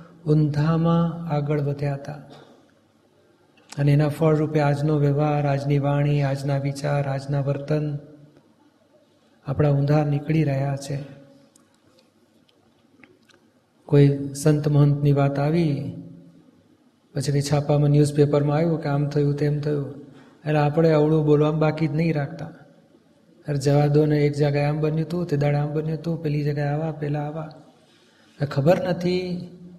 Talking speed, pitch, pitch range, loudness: 125 wpm, 150 Hz, 145-155 Hz, -22 LUFS